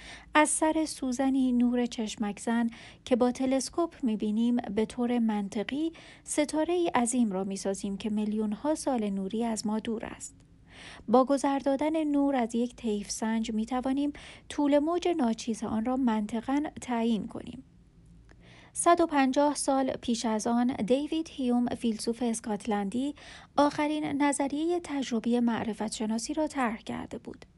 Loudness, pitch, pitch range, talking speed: -29 LUFS, 245 Hz, 225-285 Hz, 140 wpm